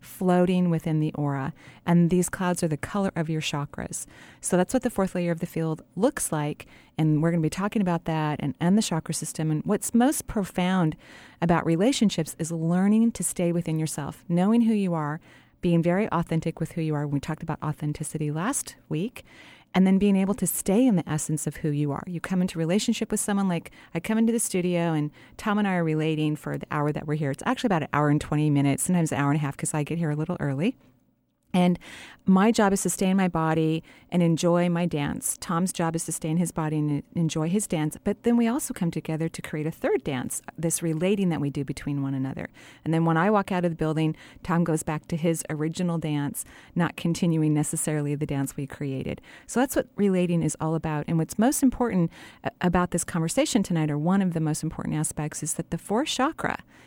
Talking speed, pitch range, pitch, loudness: 230 wpm, 155-185 Hz, 165 Hz, -26 LUFS